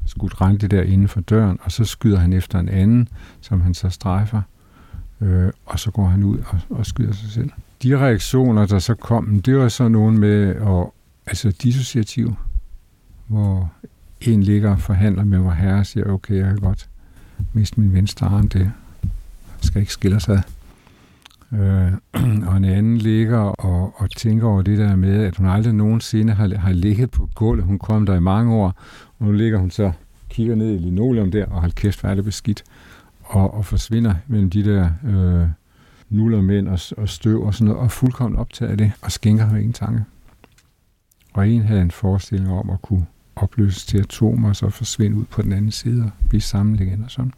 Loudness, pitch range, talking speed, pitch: -19 LUFS, 95-110 Hz, 200 wpm, 100 Hz